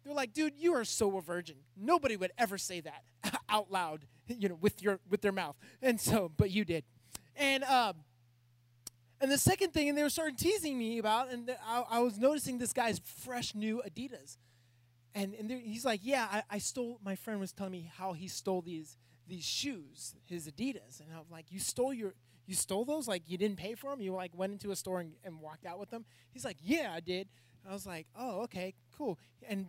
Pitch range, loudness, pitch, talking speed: 170-245 Hz, -36 LUFS, 200 Hz, 225 wpm